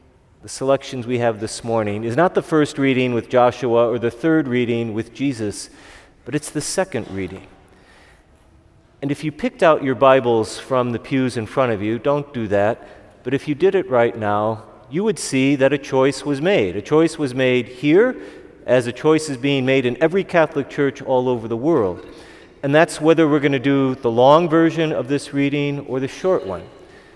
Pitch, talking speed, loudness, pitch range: 130 Hz, 205 wpm, -19 LUFS, 115-145 Hz